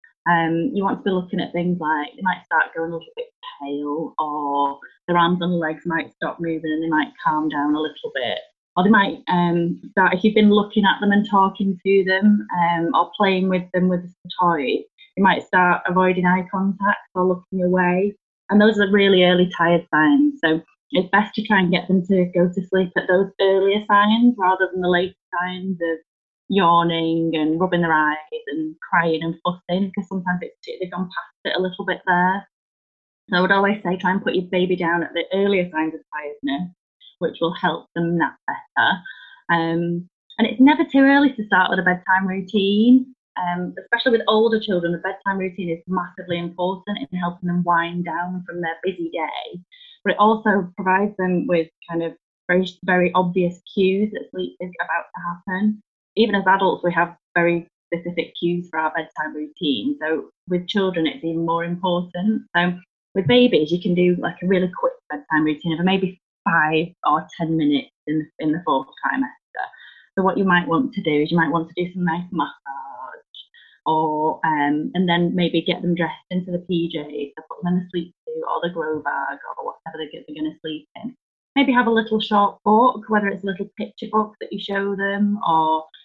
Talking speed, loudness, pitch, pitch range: 205 wpm, -20 LUFS, 180 Hz, 170-200 Hz